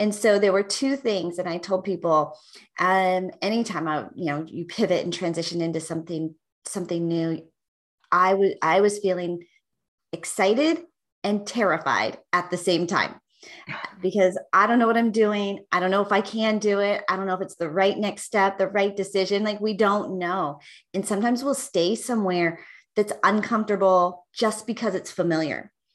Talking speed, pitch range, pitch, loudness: 180 wpm, 175-210 Hz, 190 Hz, -24 LUFS